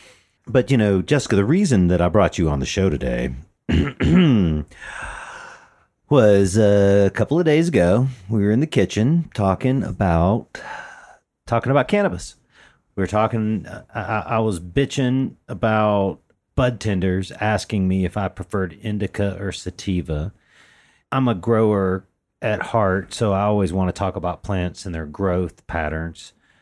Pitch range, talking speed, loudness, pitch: 90-115 Hz, 145 wpm, -20 LUFS, 100 Hz